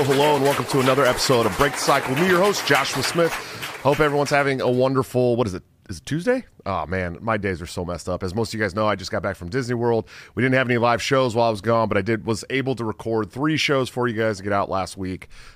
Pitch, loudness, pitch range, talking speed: 120 Hz, -21 LUFS, 105-135 Hz, 290 wpm